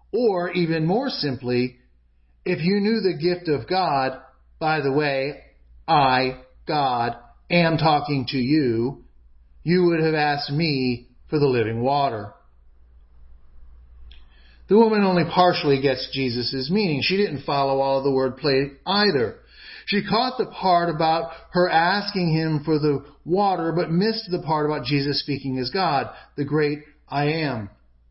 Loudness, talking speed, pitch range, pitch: -22 LUFS, 145 wpm, 125-170 Hz, 145 Hz